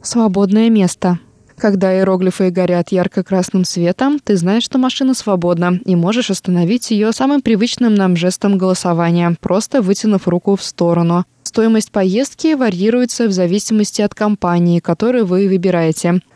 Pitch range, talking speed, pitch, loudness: 180-220 Hz, 130 wpm, 195 Hz, -14 LUFS